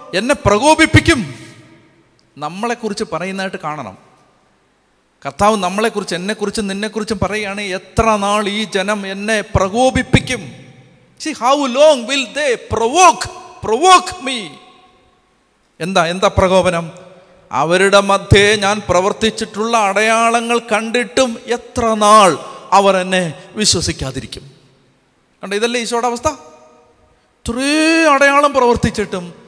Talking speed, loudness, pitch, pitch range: 75 wpm, -14 LUFS, 215 Hz, 190-240 Hz